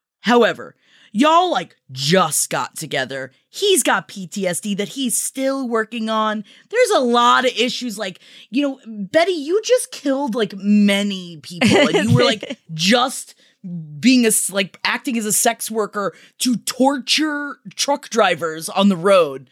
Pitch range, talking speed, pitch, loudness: 200-270 Hz, 155 wpm, 230 Hz, -18 LUFS